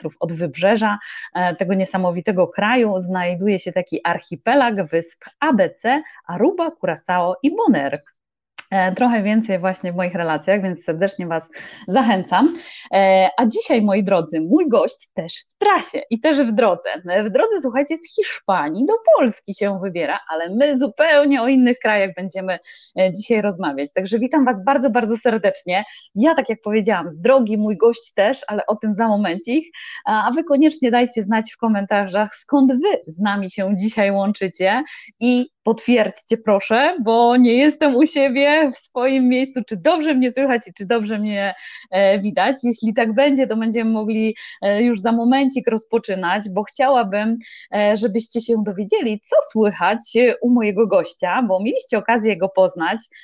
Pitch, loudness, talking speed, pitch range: 225 Hz, -18 LUFS, 155 wpm, 195-255 Hz